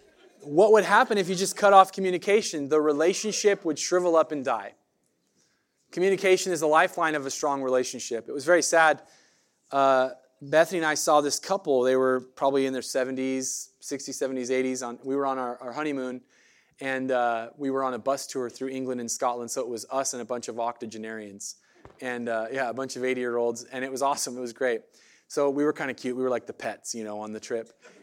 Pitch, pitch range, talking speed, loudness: 135 Hz, 125-155 Hz, 225 wpm, -26 LUFS